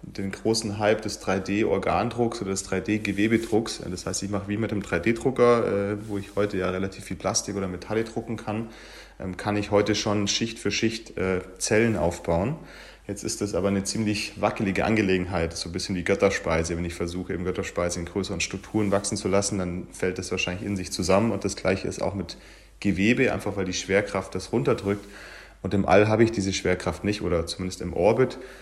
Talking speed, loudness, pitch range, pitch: 190 wpm, -26 LUFS, 95-105 Hz, 100 Hz